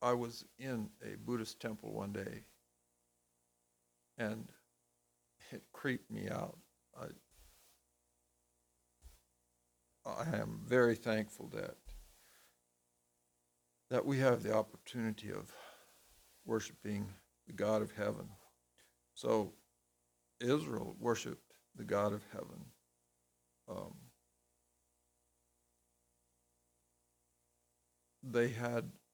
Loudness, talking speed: -39 LUFS, 80 wpm